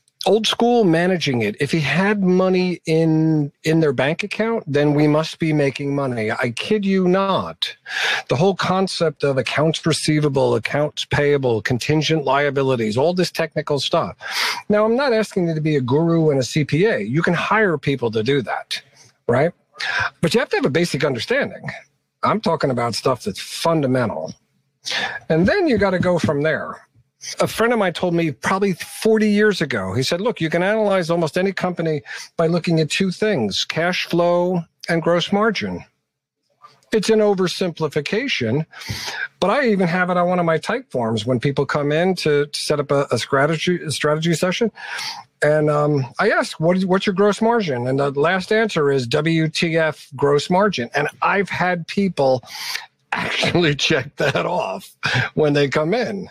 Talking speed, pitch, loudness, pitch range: 175 wpm, 165 Hz, -19 LUFS, 145-190 Hz